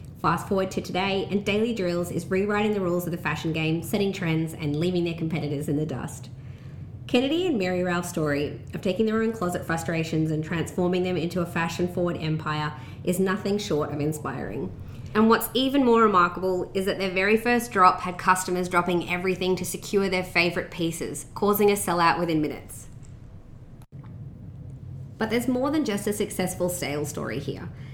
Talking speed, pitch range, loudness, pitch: 180 wpm, 150-195 Hz, -25 LUFS, 175 Hz